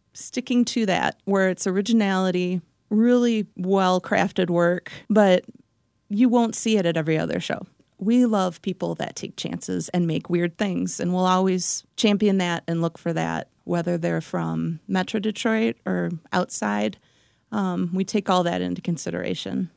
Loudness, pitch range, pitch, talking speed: -23 LUFS, 160-210 Hz, 180 Hz, 160 wpm